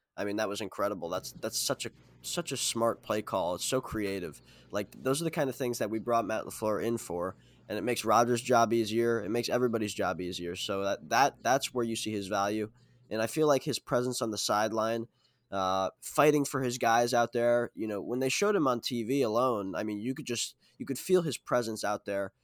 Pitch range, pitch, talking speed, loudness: 105-125 Hz, 115 Hz, 235 wpm, -31 LUFS